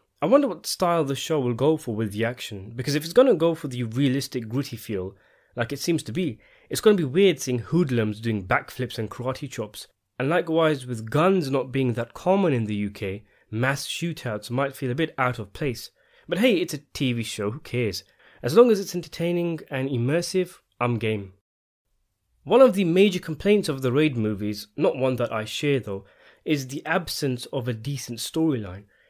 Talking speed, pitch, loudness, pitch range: 205 wpm, 130 Hz, -24 LUFS, 115-160 Hz